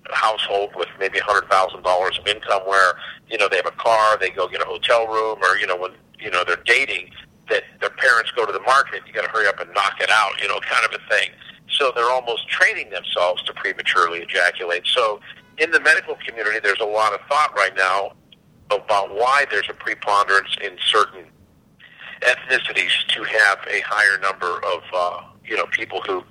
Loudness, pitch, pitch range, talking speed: -19 LUFS, 105 Hz, 95-115 Hz, 210 wpm